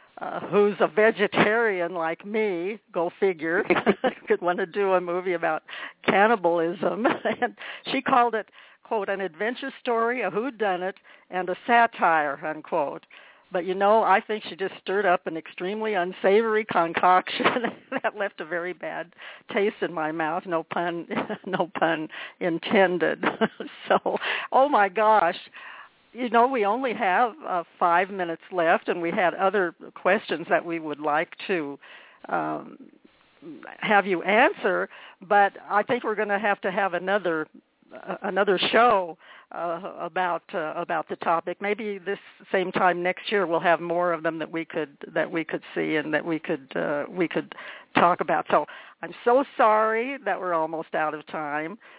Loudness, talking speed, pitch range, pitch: -25 LUFS, 165 wpm, 170-215 Hz, 190 Hz